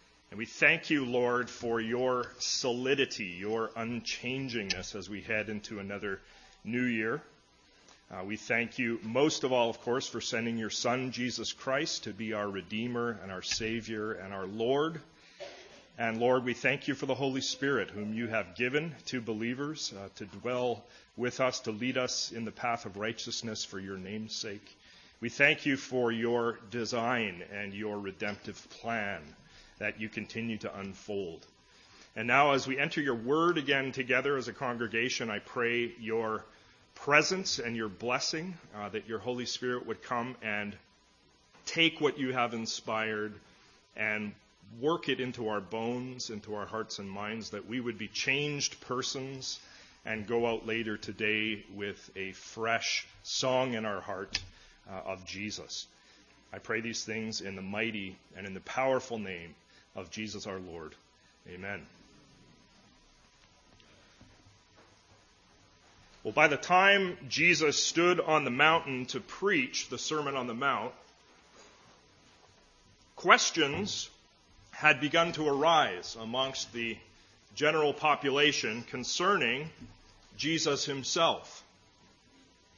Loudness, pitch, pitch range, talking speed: -31 LUFS, 115 Hz, 105-130 Hz, 145 wpm